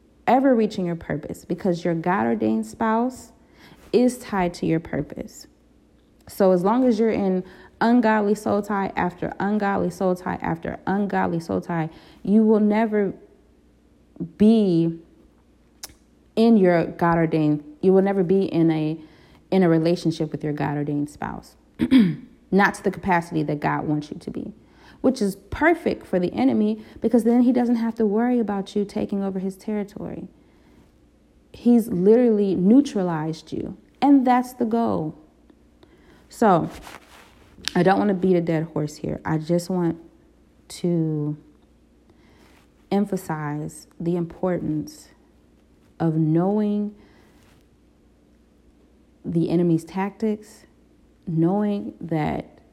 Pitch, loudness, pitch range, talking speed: 180 Hz, -22 LUFS, 155-210 Hz, 130 wpm